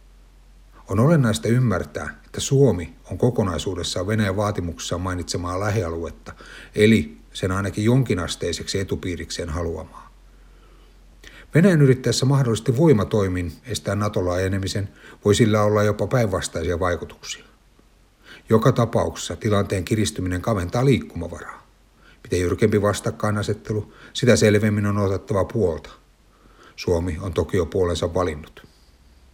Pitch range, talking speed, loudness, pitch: 90-115 Hz, 100 wpm, -22 LUFS, 105 Hz